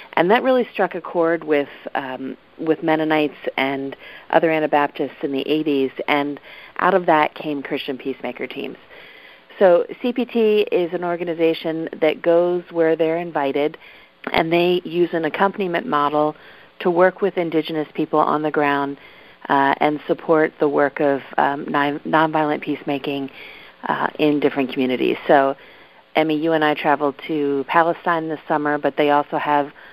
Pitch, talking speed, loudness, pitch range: 155 Hz, 150 wpm, -20 LUFS, 145-170 Hz